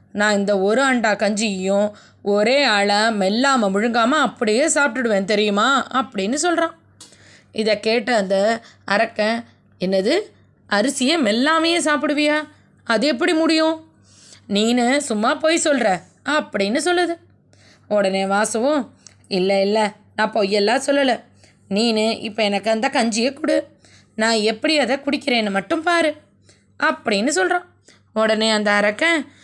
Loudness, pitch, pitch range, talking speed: -19 LUFS, 230 Hz, 210-295 Hz, 110 wpm